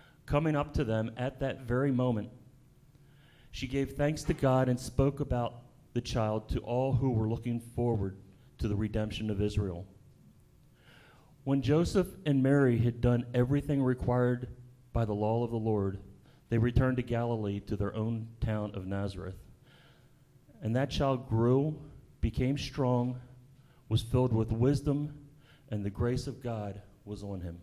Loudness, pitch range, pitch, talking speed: -32 LUFS, 110-135 Hz, 125 Hz, 155 wpm